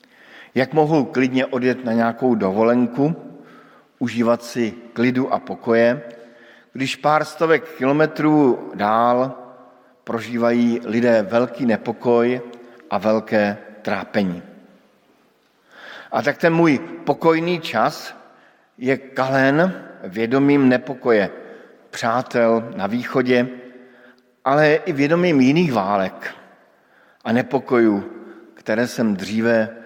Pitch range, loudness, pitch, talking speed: 115-135 Hz, -19 LUFS, 125 Hz, 95 wpm